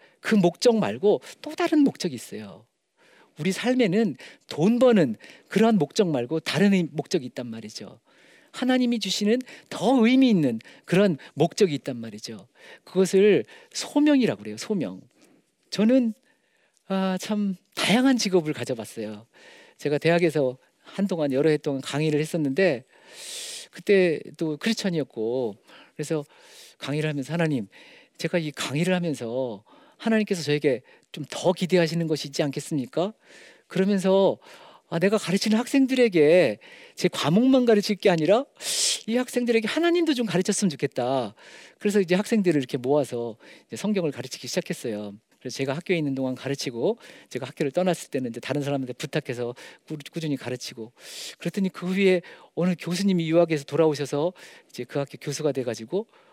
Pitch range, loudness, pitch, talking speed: 145-215 Hz, -24 LUFS, 175 Hz, 340 characters per minute